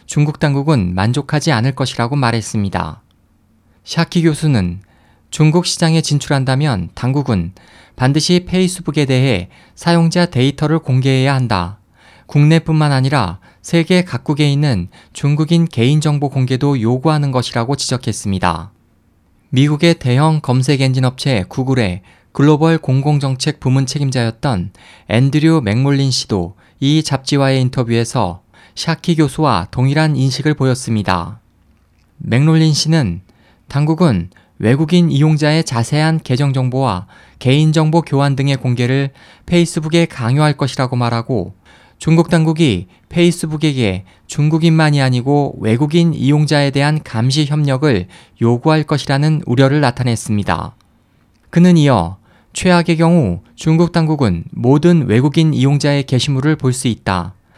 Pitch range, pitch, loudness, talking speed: 115-155 Hz, 135 Hz, -14 LUFS, 300 characters per minute